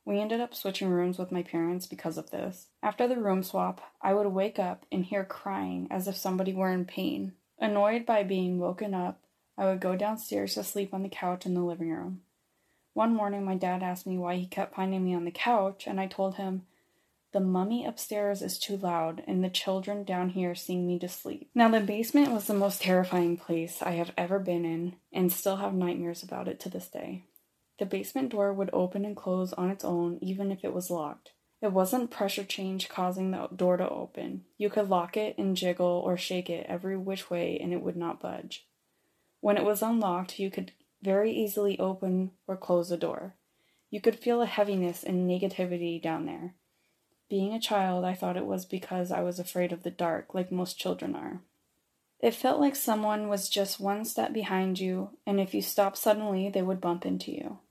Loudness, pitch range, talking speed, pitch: -31 LUFS, 180-200 Hz, 210 wpm, 190 Hz